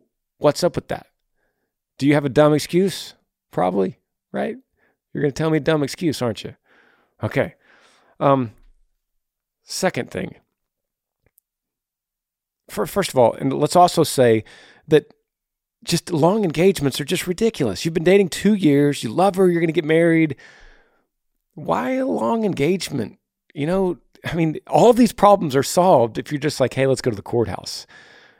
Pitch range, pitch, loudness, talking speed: 140-185 Hz, 160 Hz, -19 LUFS, 165 wpm